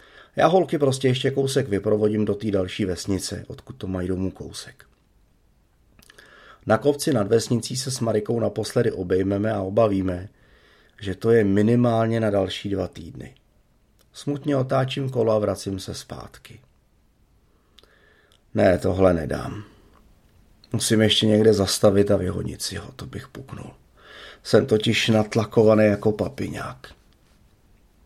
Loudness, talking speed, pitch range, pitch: -22 LUFS, 130 wpm, 100-115 Hz, 105 Hz